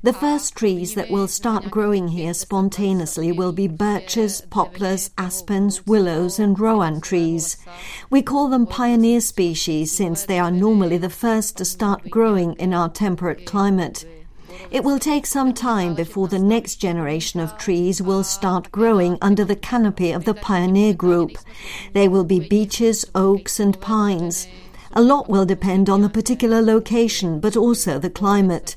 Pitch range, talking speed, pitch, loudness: 180-220 Hz, 160 wpm, 195 Hz, -19 LUFS